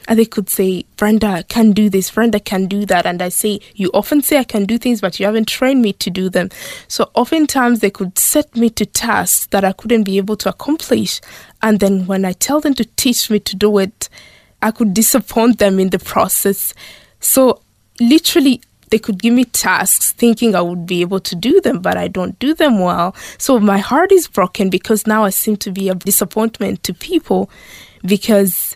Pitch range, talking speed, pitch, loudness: 195-235 Hz, 215 wpm, 215 Hz, -14 LUFS